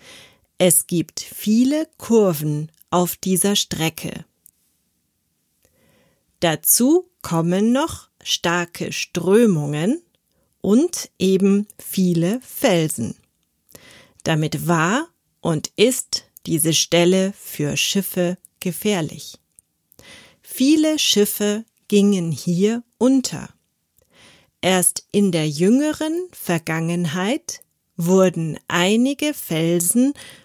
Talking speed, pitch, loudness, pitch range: 75 wpm, 185 Hz, -19 LUFS, 165-230 Hz